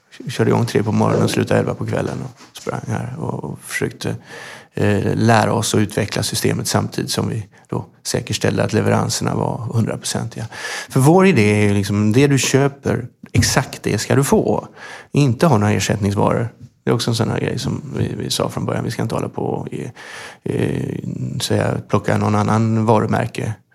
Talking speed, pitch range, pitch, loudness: 190 wpm, 105-125 Hz, 110 Hz, -18 LUFS